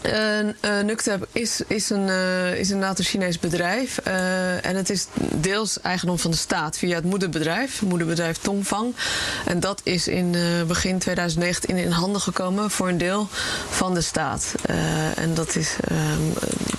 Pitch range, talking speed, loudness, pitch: 175-205 Hz, 155 wpm, -23 LUFS, 185 Hz